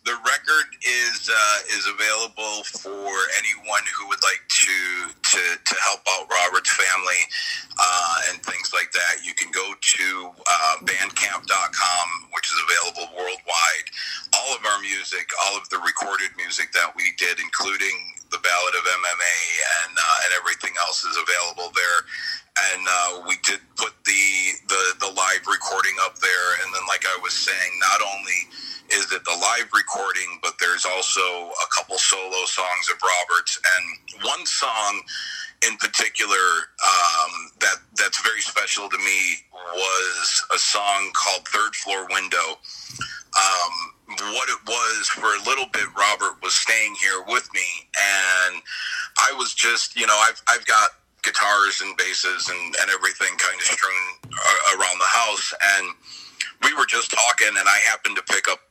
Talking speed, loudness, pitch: 160 wpm, -20 LUFS, 105 Hz